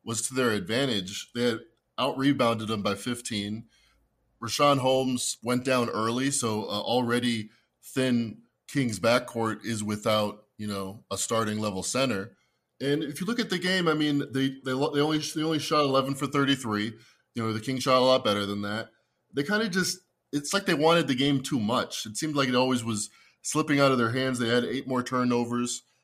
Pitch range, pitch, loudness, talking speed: 110-140 Hz, 125 Hz, -27 LUFS, 200 wpm